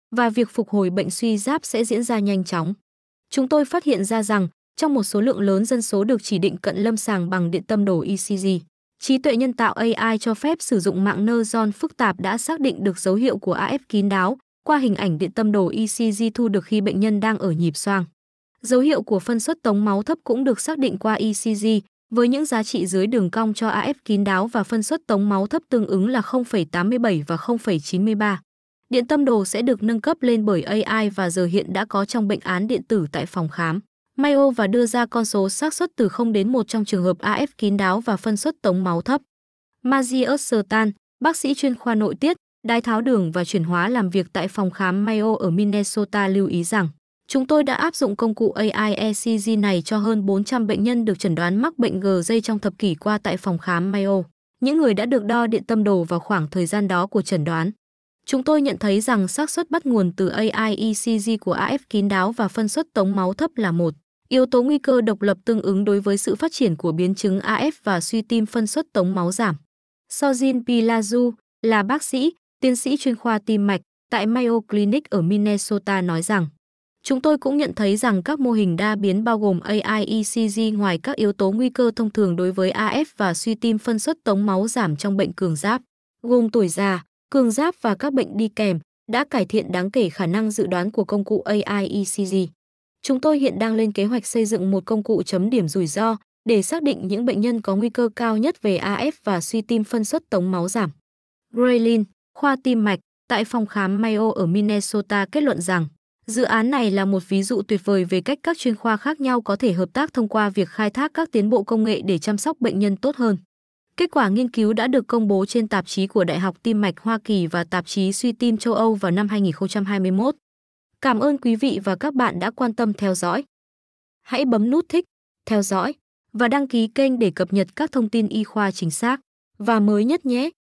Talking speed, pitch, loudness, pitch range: 235 wpm, 215 Hz, -21 LUFS, 195-245 Hz